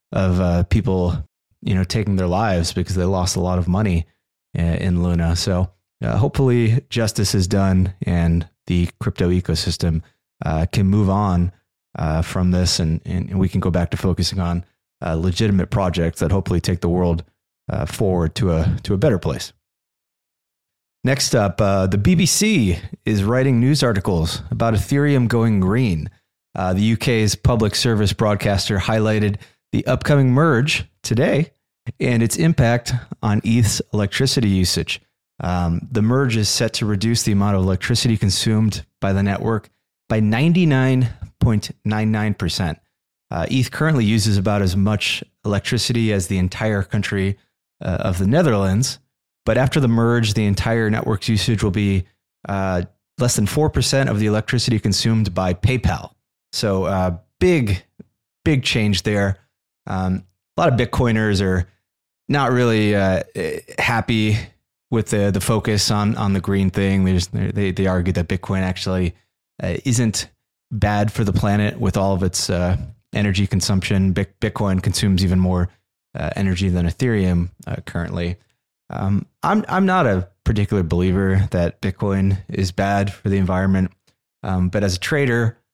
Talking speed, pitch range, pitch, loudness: 155 wpm, 90-115 Hz, 100 Hz, -19 LUFS